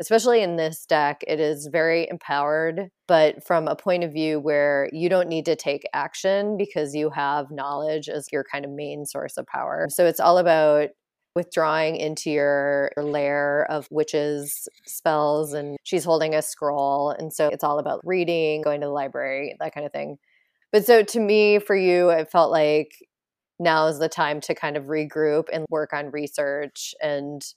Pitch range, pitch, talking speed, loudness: 145-170 Hz, 155 Hz, 185 wpm, -23 LUFS